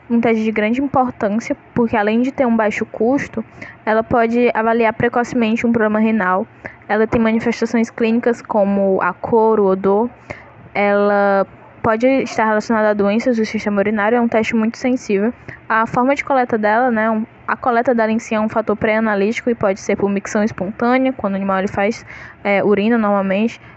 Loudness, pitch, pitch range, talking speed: -17 LUFS, 220 Hz, 205-235 Hz, 180 wpm